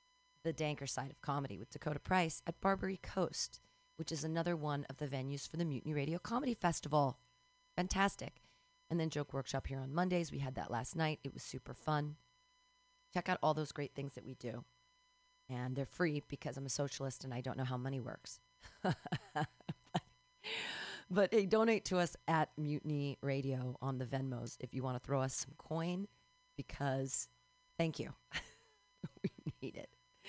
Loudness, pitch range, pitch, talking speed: -40 LUFS, 130-180 Hz, 145 Hz, 175 wpm